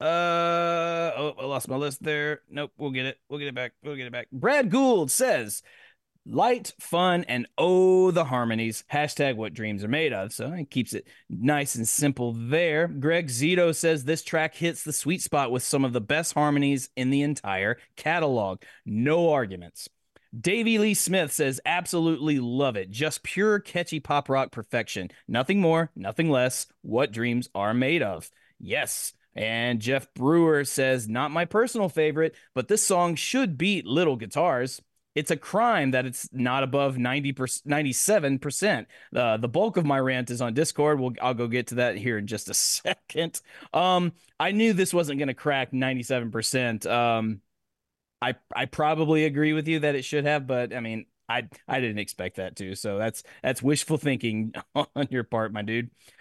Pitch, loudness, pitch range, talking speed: 140 Hz, -26 LUFS, 125-160 Hz, 180 wpm